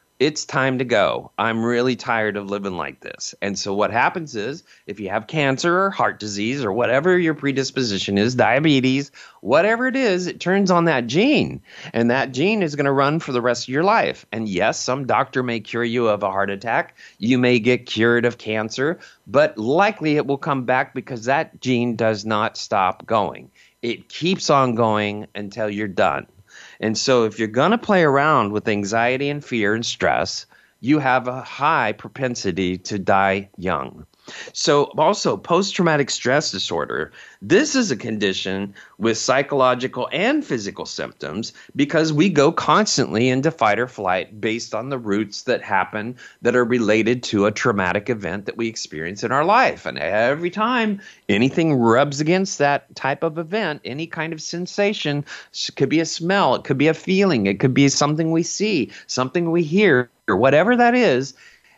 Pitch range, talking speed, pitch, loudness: 110-160 Hz, 185 wpm, 130 Hz, -20 LUFS